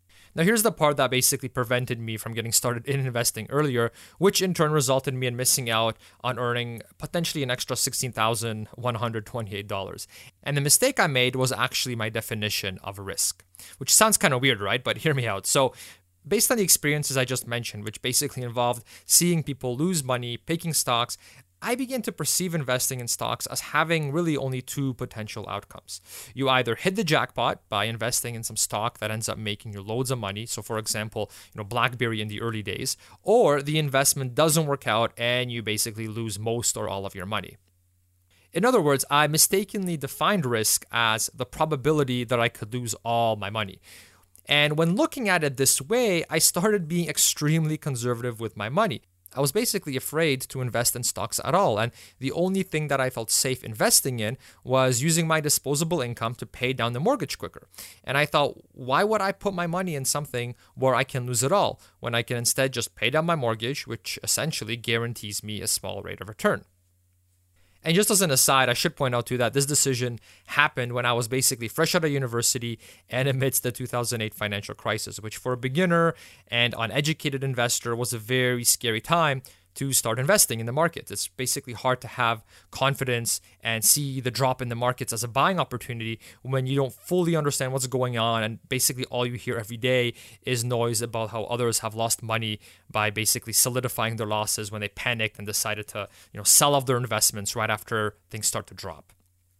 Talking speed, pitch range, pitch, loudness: 200 wpm, 110-140 Hz, 125 Hz, -24 LUFS